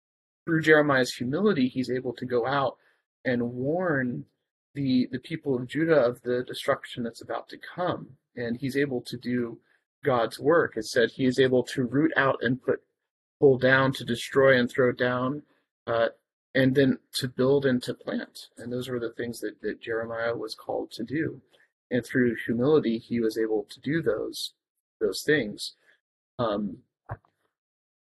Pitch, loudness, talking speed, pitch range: 125 Hz, -27 LUFS, 165 wpm, 120-140 Hz